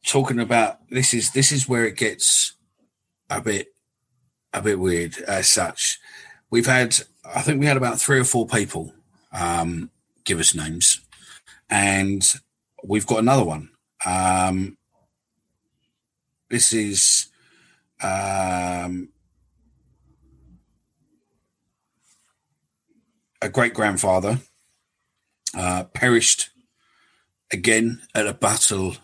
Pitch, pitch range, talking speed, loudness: 105 Hz, 90-125 Hz, 100 wpm, -20 LUFS